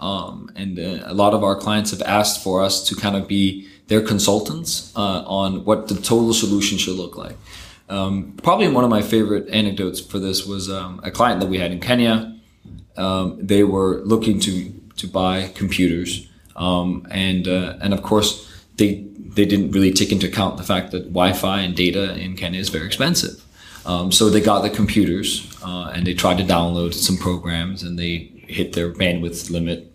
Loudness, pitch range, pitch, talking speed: -19 LUFS, 90-100 Hz, 95 Hz, 195 wpm